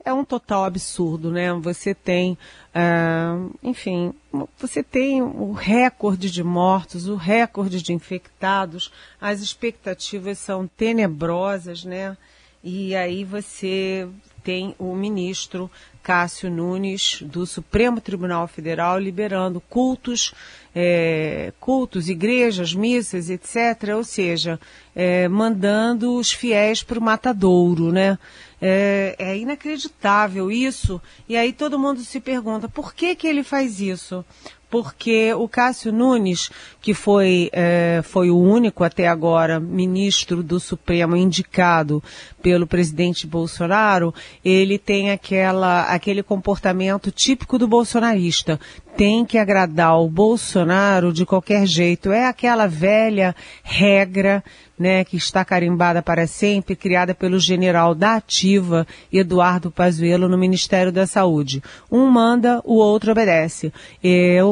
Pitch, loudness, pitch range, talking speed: 190 Hz, -19 LUFS, 175-215 Hz, 120 wpm